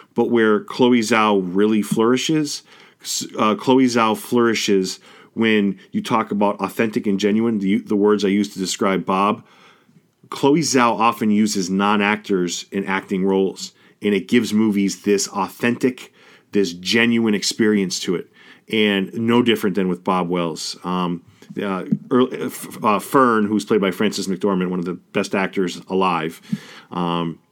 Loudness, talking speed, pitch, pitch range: -19 LUFS, 145 wpm, 105 Hz, 95-115 Hz